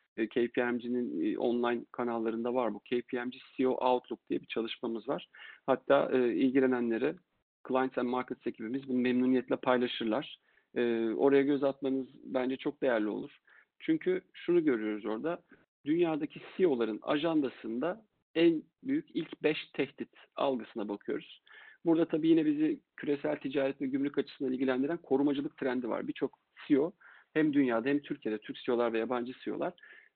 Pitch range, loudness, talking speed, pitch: 125-165 Hz, -32 LUFS, 135 wpm, 135 Hz